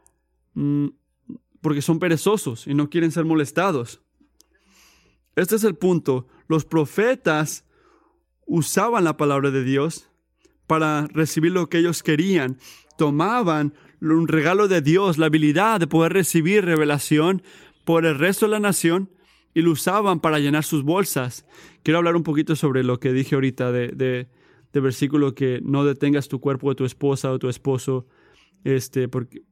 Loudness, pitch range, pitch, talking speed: -21 LUFS, 135-170 Hz, 155 Hz, 150 wpm